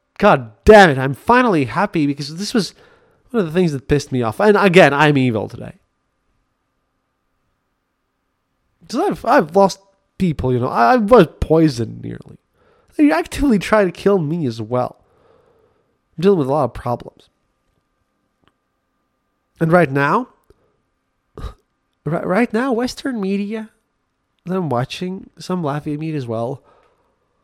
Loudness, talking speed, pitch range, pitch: -16 LUFS, 140 wpm, 145-220 Hz, 185 Hz